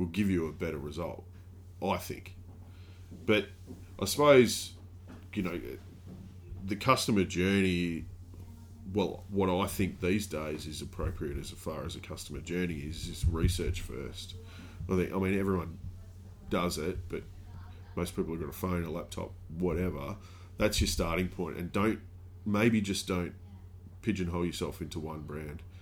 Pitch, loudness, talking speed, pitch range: 90 Hz, -32 LUFS, 150 wpm, 85-95 Hz